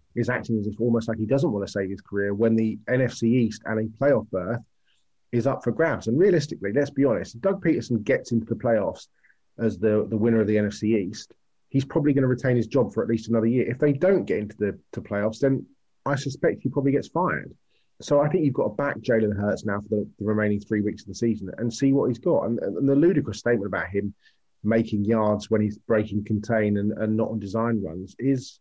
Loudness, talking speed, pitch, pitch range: -24 LUFS, 240 wpm, 115 Hz, 105-130 Hz